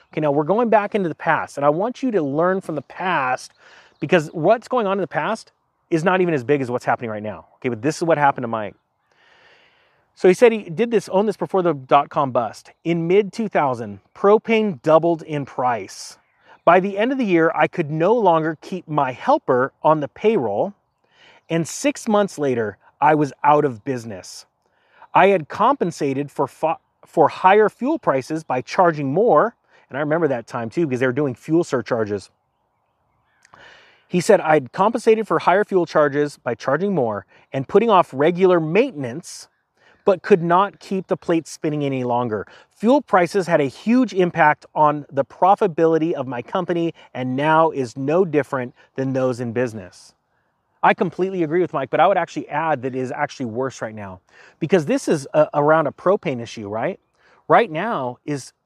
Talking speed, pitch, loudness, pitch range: 190 wpm, 160 Hz, -19 LUFS, 135-190 Hz